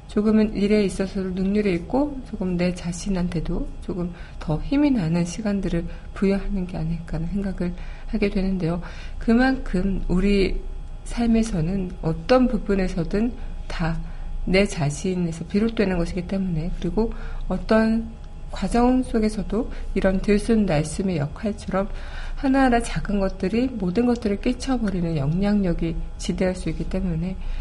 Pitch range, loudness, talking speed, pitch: 175-215 Hz, -24 LUFS, 300 characters per minute, 190 Hz